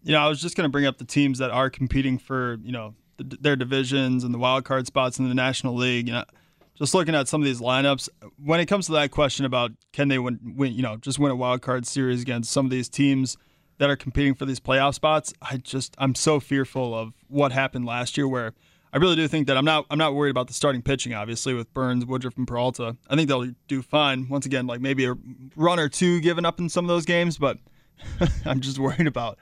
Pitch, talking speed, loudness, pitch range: 135 Hz, 255 wpm, -24 LUFS, 125-145 Hz